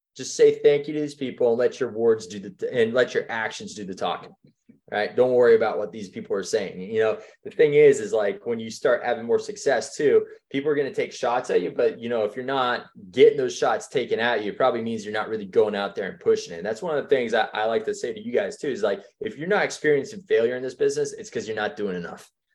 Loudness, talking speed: -24 LUFS, 285 wpm